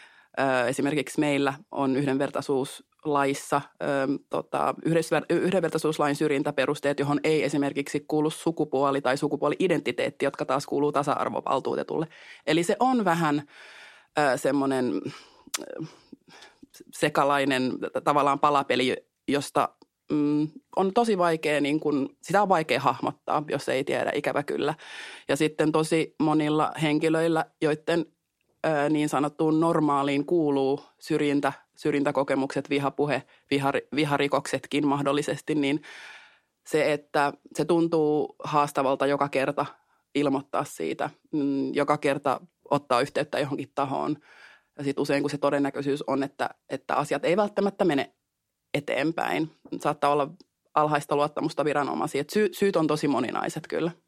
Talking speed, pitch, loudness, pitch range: 105 wpm, 145 Hz, -26 LUFS, 140-155 Hz